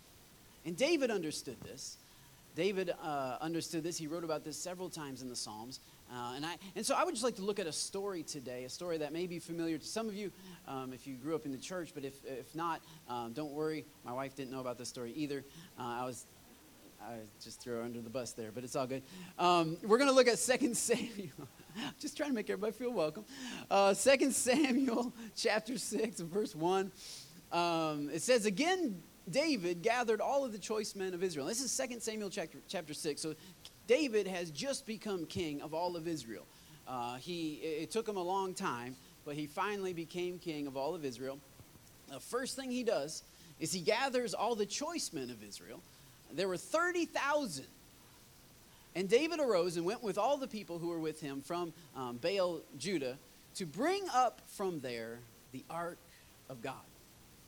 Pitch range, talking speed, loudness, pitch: 145-220 Hz, 200 wpm, -37 LUFS, 175 Hz